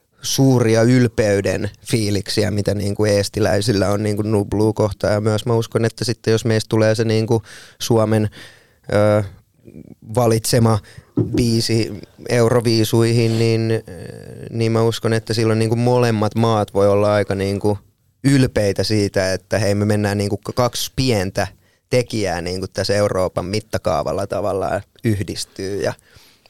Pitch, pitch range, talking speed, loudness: 110 Hz, 100-115 Hz, 130 wpm, -18 LUFS